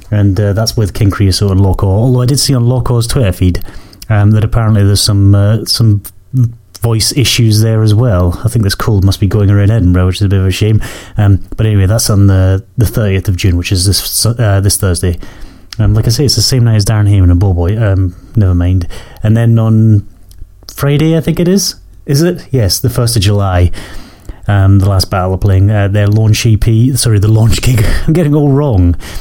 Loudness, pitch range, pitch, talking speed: -10 LUFS, 95-115 Hz, 105 Hz, 225 wpm